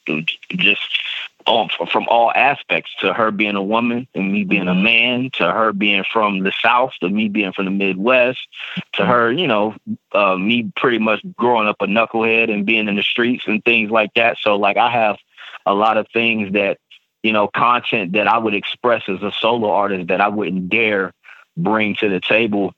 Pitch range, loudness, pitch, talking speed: 100-115 Hz, -16 LUFS, 110 Hz, 200 wpm